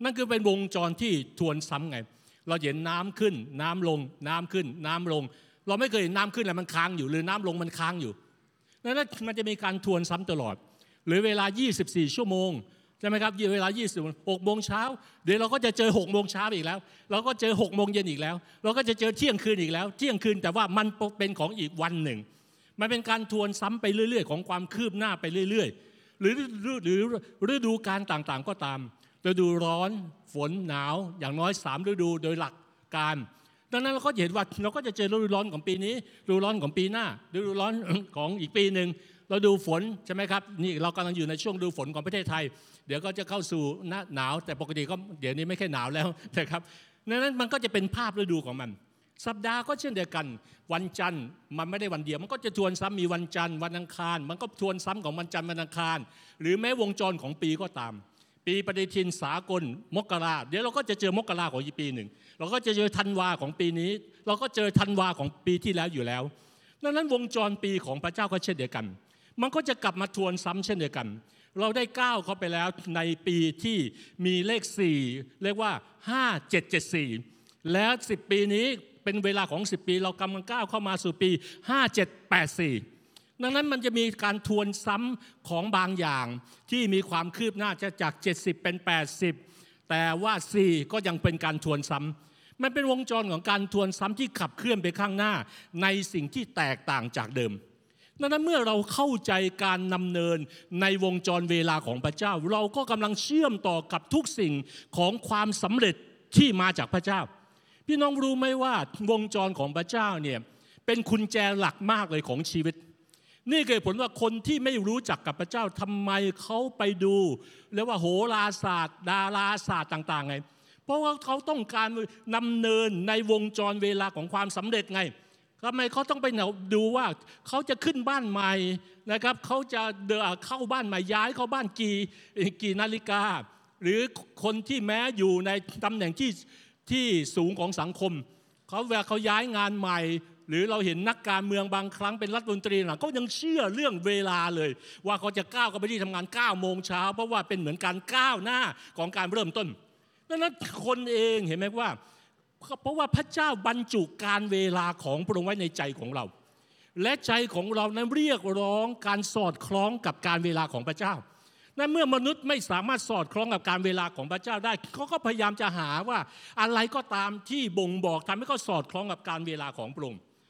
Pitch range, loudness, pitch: 170-220 Hz, -29 LUFS, 195 Hz